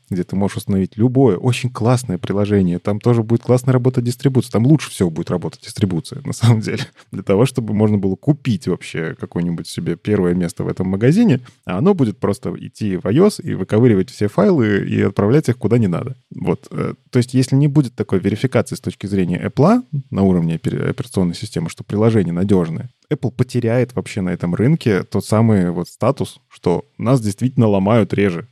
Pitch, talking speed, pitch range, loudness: 115 Hz, 185 wpm, 100-130 Hz, -17 LUFS